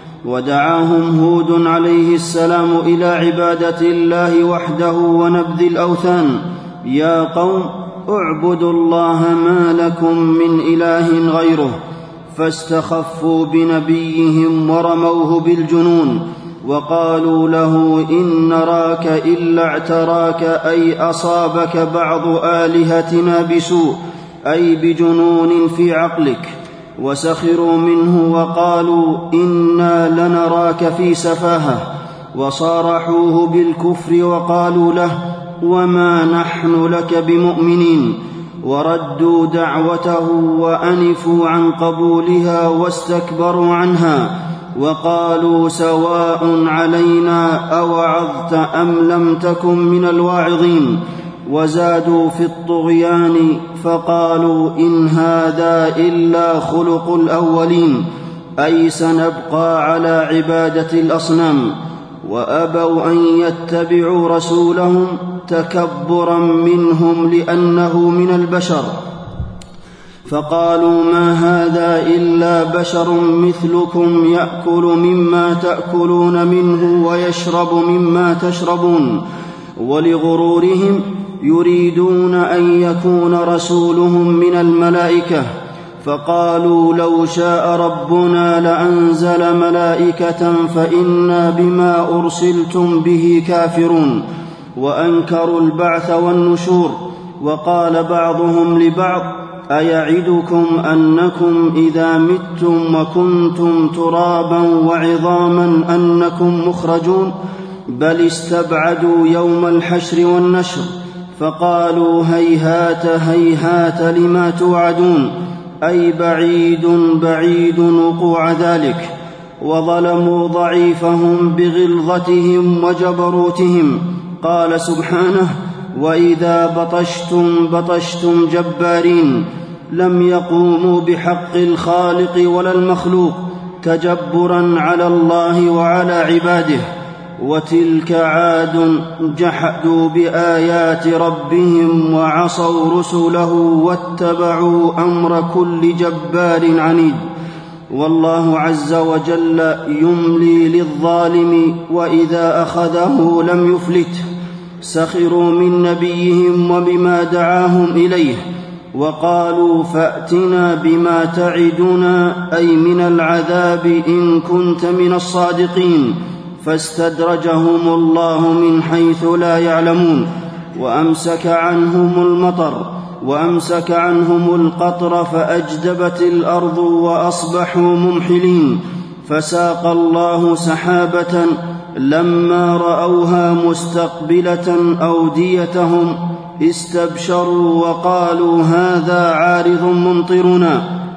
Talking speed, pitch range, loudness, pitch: 75 wpm, 165-175 Hz, -13 LUFS, 170 Hz